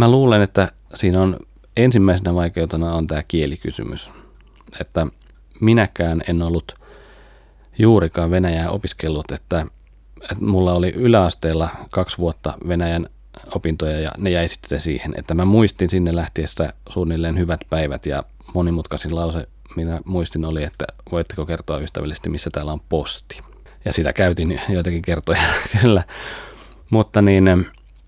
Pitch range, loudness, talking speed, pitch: 80-95 Hz, -20 LUFS, 135 wpm, 85 Hz